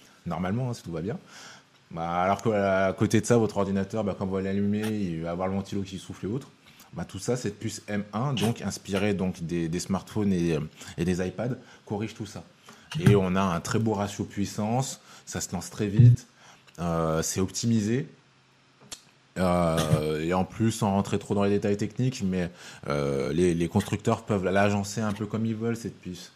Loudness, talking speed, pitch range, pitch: -27 LUFS, 200 wpm, 95-110 Hz, 100 Hz